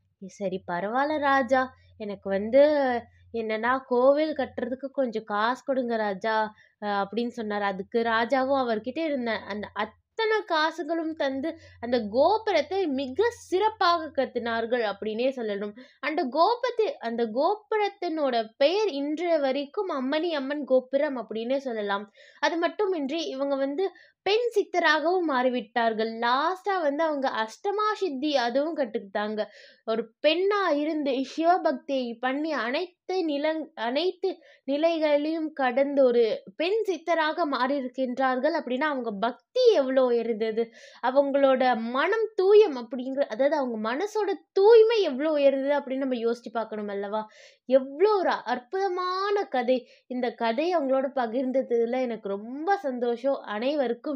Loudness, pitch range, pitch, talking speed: -26 LUFS, 235-325 Hz, 275 Hz, 110 wpm